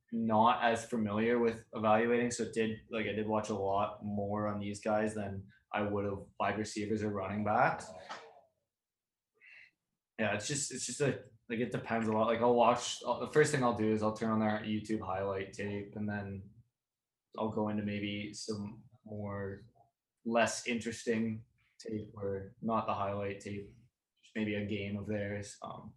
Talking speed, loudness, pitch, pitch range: 180 wpm, -34 LUFS, 110 Hz, 105-115 Hz